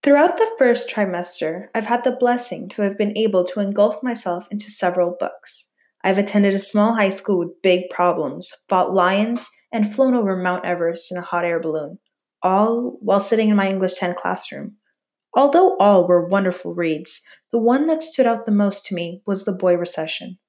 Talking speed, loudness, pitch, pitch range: 190 wpm, -19 LUFS, 200 Hz, 180-225 Hz